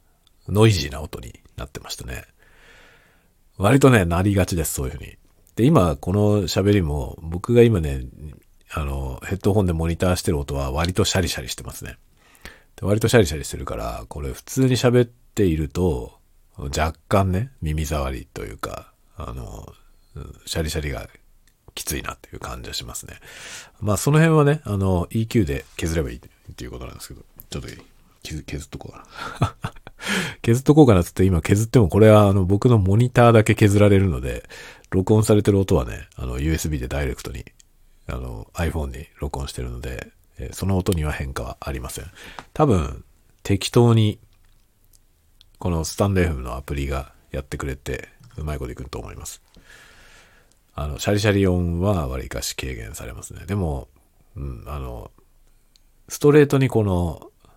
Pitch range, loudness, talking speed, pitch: 75-105 Hz, -21 LUFS, 350 characters per minute, 90 Hz